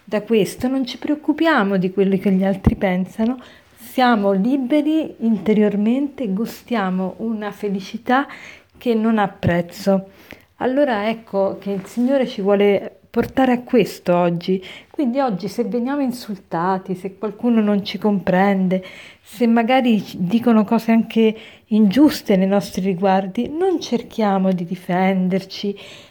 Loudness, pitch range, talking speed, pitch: -19 LUFS, 195-240 Hz, 130 wpm, 215 Hz